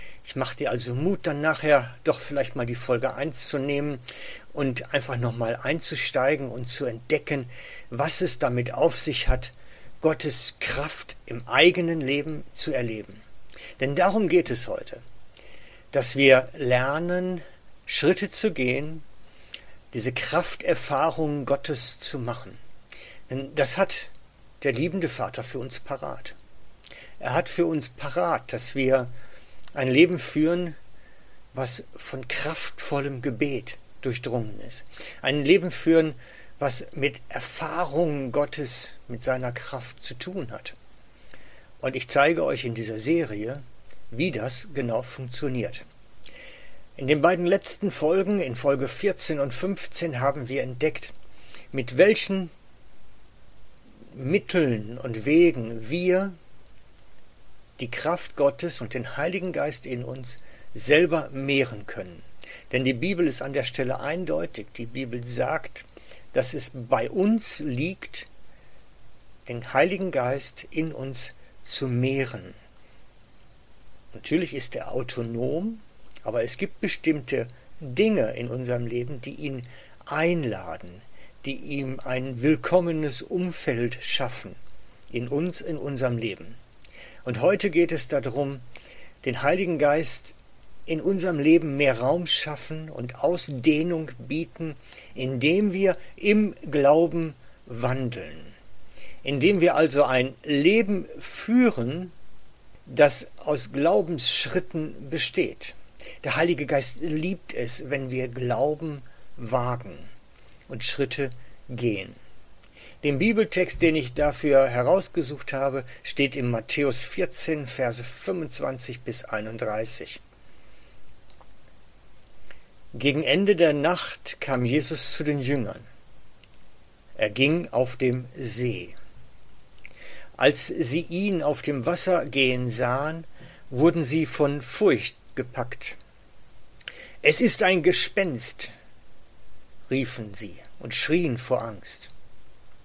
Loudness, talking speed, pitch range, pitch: -25 LUFS, 115 wpm, 125-160 Hz, 140 Hz